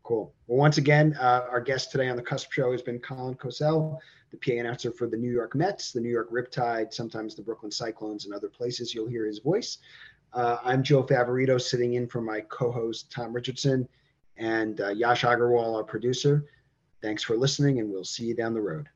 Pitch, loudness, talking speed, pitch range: 120 Hz, -27 LUFS, 210 wpm, 115-135 Hz